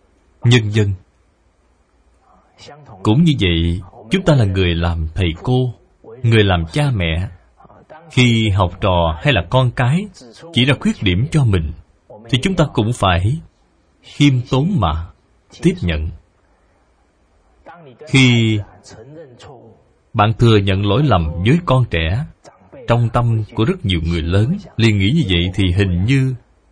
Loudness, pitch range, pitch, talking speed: -16 LUFS, 85-125 Hz, 105 Hz, 140 wpm